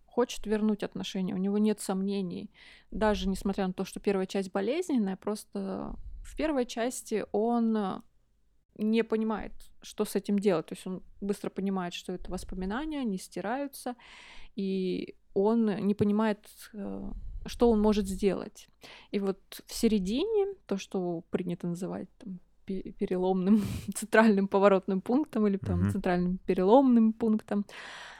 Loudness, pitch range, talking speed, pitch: -30 LUFS, 190-220 Hz, 130 wpm, 205 Hz